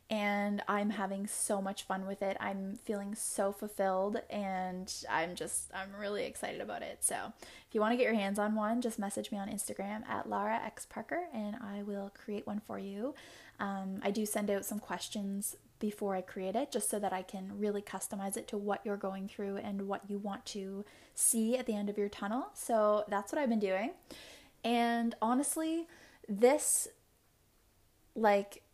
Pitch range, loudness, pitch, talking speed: 195-220 Hz, -36 LUFS, 205 Hz, 190 wpm